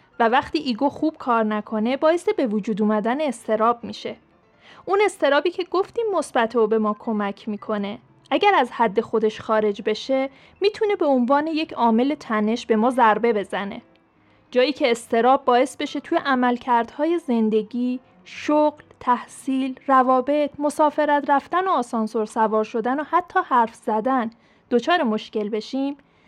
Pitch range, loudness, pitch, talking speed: 225-295 Hz, -21 LUFS, 250 Hz, 140 wpm